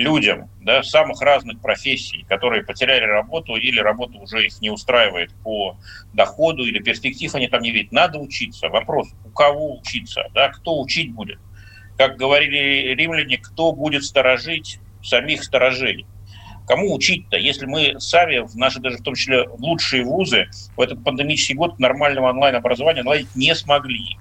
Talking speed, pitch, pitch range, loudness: 155 wpm, 125 Hz, 105-145 Hz, -18 LUFS